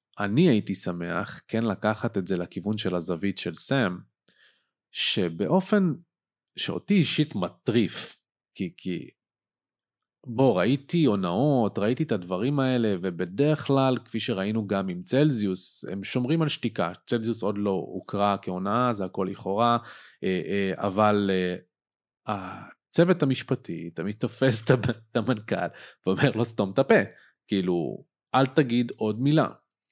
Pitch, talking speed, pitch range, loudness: 110 Hz, 120 wpm, 95-130 Hz, -26 LUFS